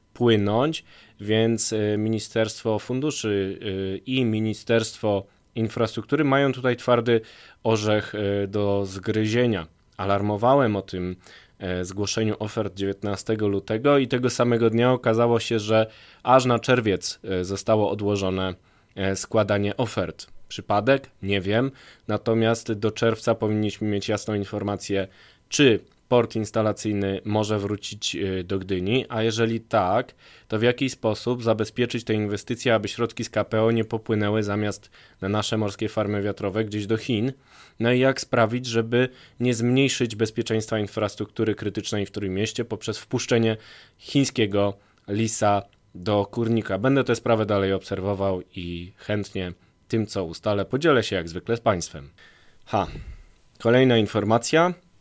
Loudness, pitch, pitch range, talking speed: -24 LUFS, 110 Hz, 100-115 Hz, 125 wpm